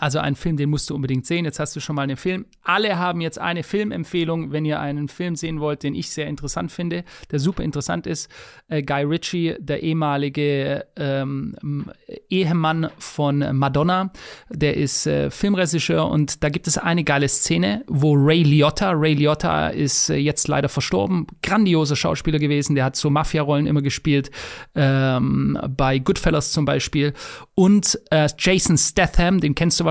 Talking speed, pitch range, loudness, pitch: 175 wpm, 145-170 Hz, -20 LUFS, 150 Hz